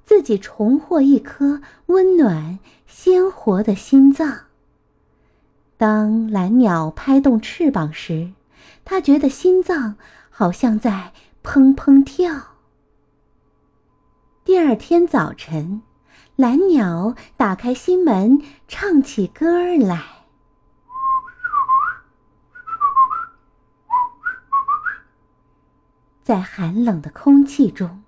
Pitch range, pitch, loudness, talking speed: 215-355 Hz, 275 Hz, -17 LUFS, 115 characters per minute